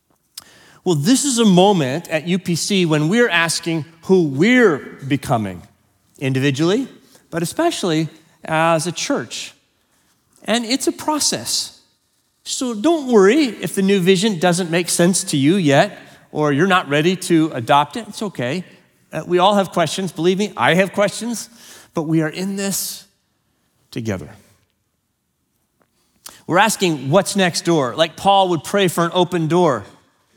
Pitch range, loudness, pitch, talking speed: 155-200 Hz, -17 LUFS, 180 Hz, 145 wpm